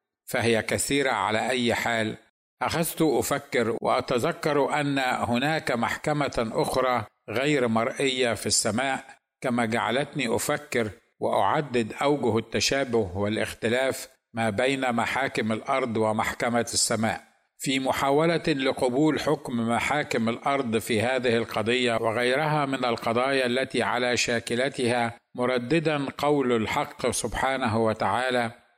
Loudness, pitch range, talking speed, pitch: -25 LUFS, 115-140 Hz, 100 wpm, 125 Hz